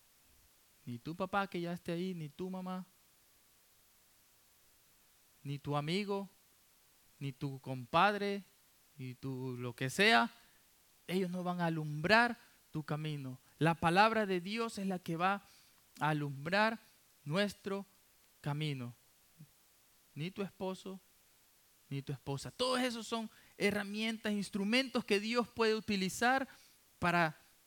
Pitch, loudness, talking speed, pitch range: 180 Hz, -36 LUFS, 120 wpm, 145-205 Hz